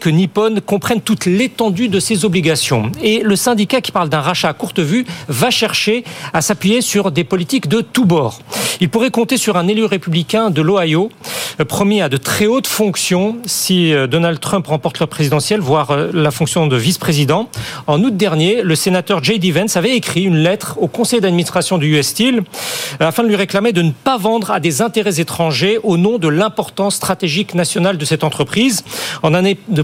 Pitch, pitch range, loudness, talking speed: 190 Hz, 165-215 Hz, -14 LUFS, 190 wpm